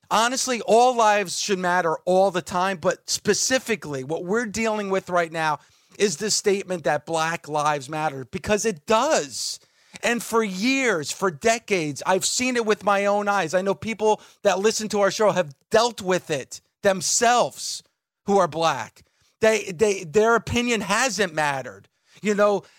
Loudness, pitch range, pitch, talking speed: -22 LUFS, 180-220 Hz, 200 Hz, 165 wpm